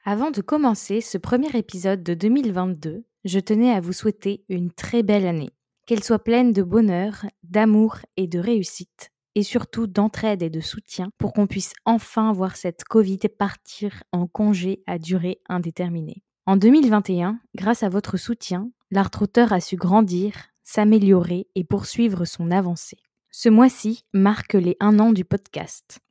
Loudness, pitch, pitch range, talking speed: -21 LUFS, 205 Hz, 185-220 Hz, 155 wpm